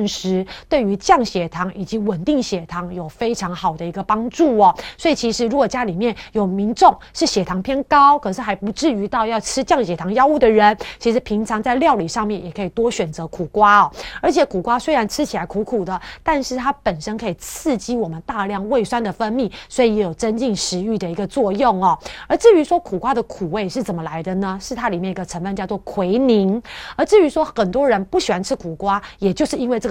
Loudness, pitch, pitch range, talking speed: -18 LUFS, 215 Hz, 190-255 Hz, 330 characters per minute